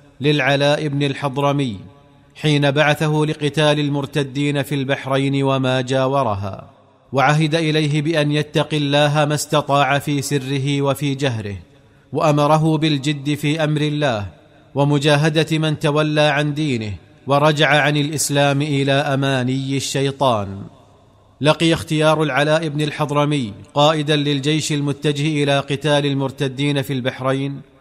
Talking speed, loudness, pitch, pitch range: 110 wpm, -18 LUFS, 145 Hz, 135-150 Hz